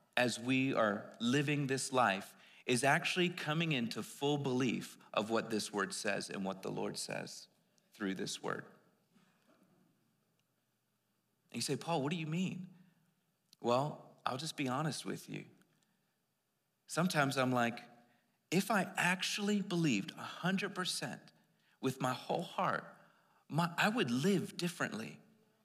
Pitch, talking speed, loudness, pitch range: 145 Hz, 135 wpm, -36 LUFS, 125-180 Hz